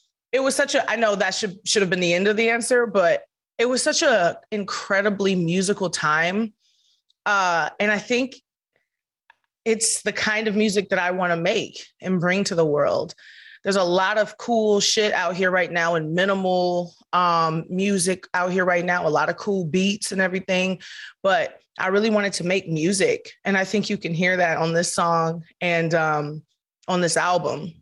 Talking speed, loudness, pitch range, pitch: 195 wpm, -21 LUFS, 175-215 Hz, 190 Hz